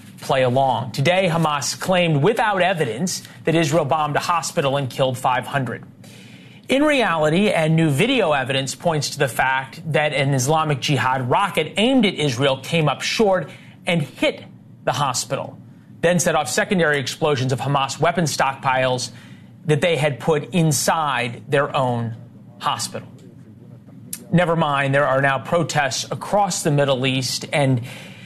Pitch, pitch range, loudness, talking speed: 150 Hz, 135-170 Hz, -20 LUFS, 145 wpm